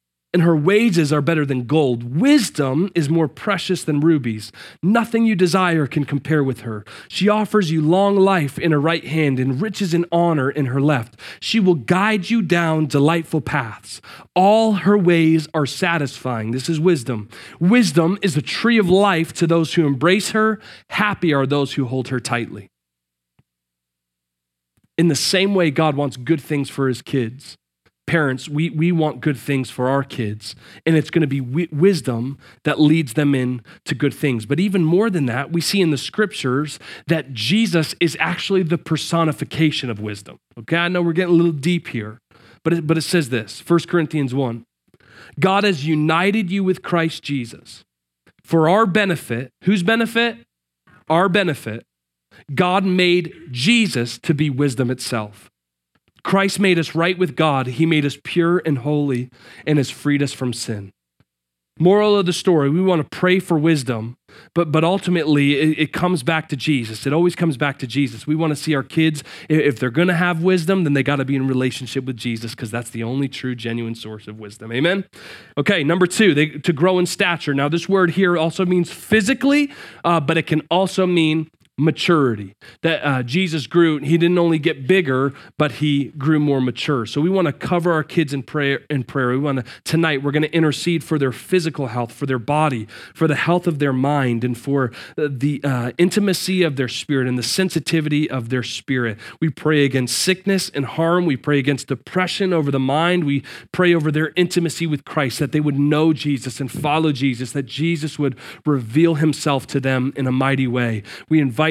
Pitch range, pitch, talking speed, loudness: 130-175 Hz, 155 Hz, 190 wpm, -19 LUFS